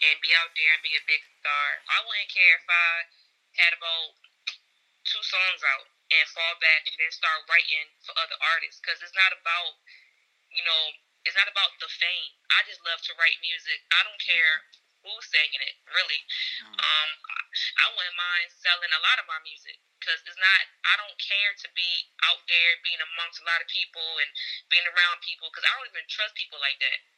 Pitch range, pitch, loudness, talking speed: 160-185 Hz, 170 Hz, -24 LUFS, 200 wpm